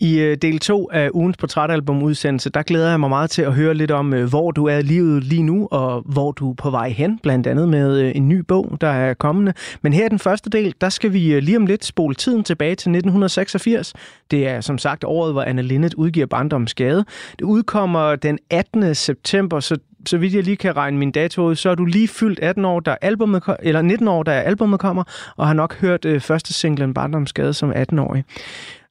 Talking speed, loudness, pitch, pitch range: 220 wpm, -18 LUFS, 160 Hz, 145-185 Hz